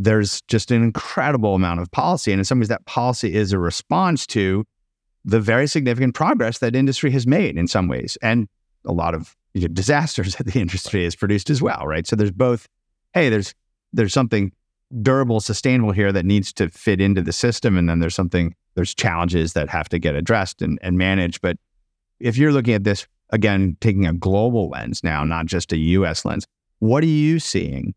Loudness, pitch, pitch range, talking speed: -20 LUFS, 105 Hz, 90-120 Hz, 205 wpm